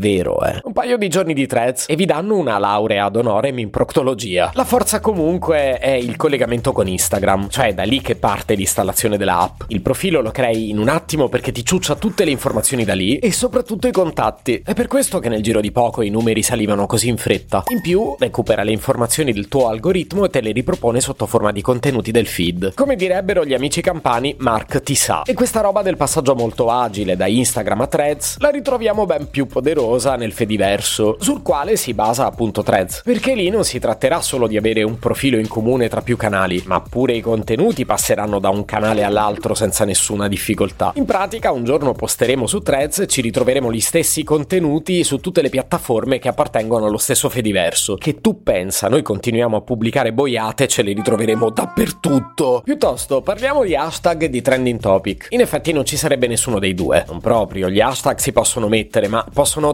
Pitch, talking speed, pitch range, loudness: 125 Hz, 200 wpm, 110-160 Hz, -17 LUFS